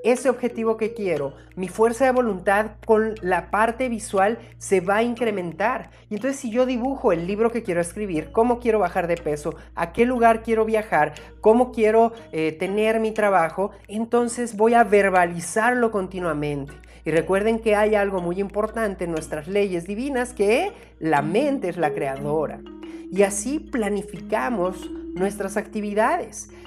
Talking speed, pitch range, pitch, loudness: 160 wpm, 185-230 Hz, 210 Hz, -22 LUFS